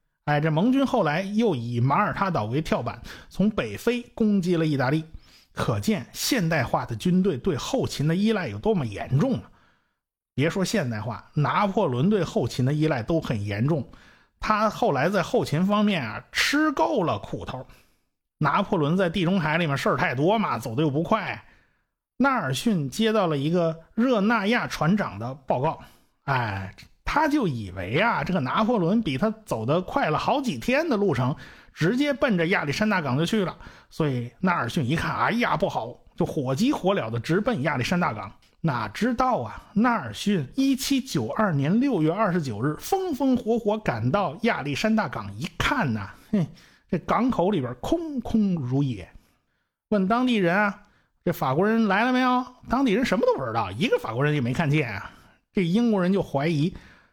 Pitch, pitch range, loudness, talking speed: 180 Hz, 145-220 Hz, -24 LUFS, 265 characters per minute